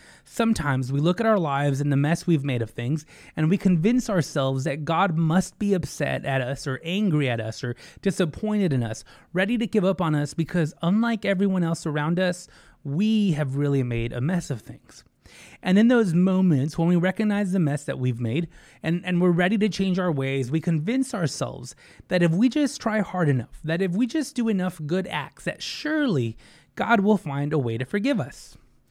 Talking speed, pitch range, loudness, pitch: 210 wpm, 140-195 Hz, -24 LUFS, 170 Hz